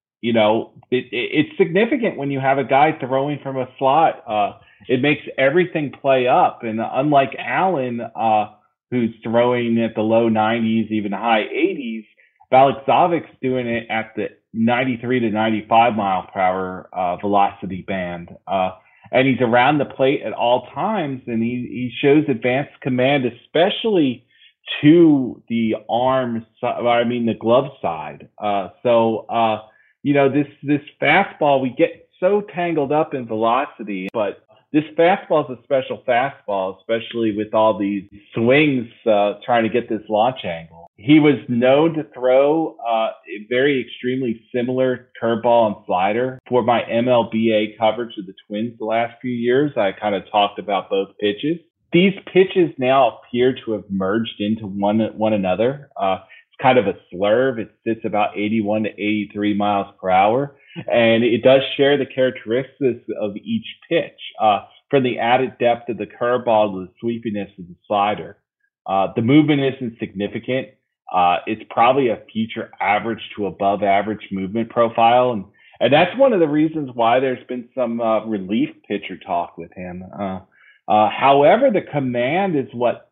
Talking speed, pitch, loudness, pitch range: 165 wpm, 120 Hz, -19 LUFS, 105-135 Hz